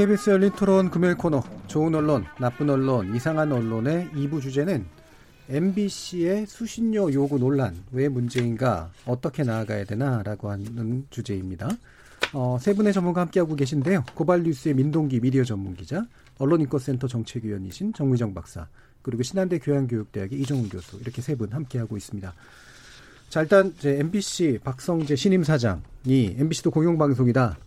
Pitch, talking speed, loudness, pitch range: 140 Hz, 365 characters per minute, -24 LUFS, 120-170 Hz